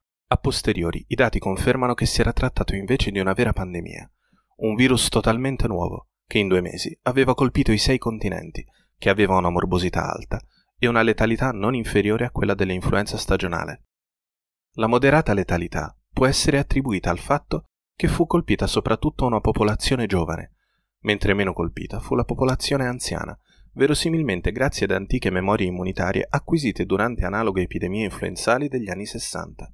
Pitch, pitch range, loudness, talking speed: 110 Hz, 95-130 Hz, -22 LUFS, 155 wpm